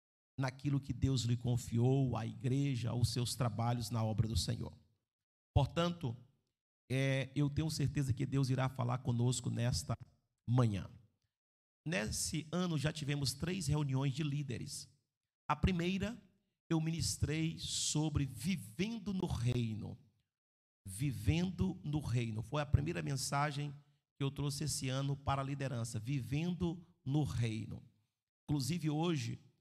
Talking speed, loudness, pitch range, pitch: 125 wpm, -37 LUFS, 120-150 Hz, 135 Hz